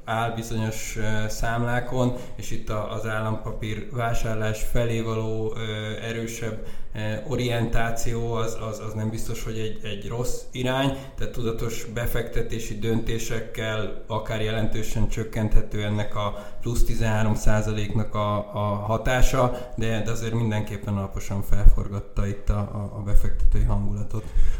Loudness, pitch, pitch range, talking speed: -28 LUFS, 110 Hz, 105-115 Hz, 110 wpm